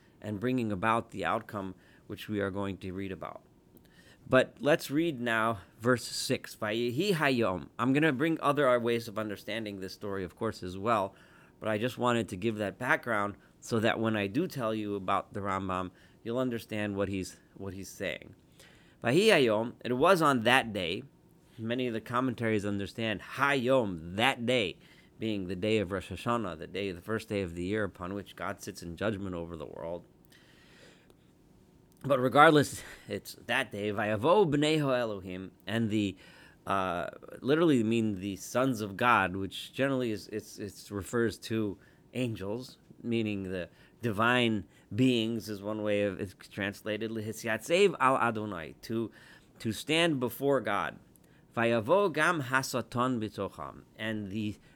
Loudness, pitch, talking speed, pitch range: -31 LUFS, 110 Hz, 155 wpm, 100-125 Hz